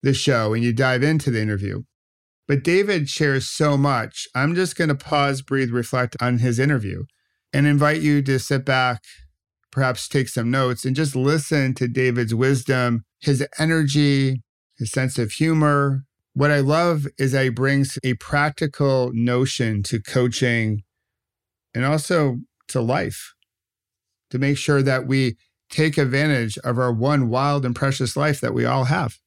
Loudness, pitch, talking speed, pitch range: -21 LUFS, 130 Hz, 160 wpm, 120-145 Hz